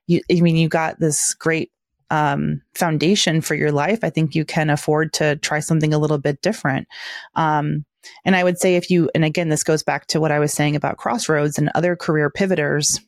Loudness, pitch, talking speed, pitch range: -19 LUFS, 155 Hz, 215 wpm, 150-170 Hz